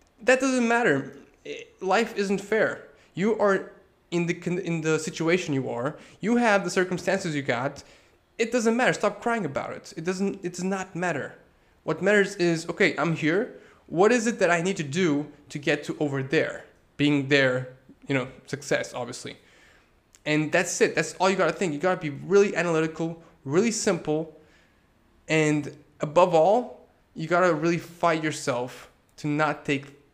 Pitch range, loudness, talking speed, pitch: 150-195 Hz, -25 LUFS, 170 wpm, 170 Hz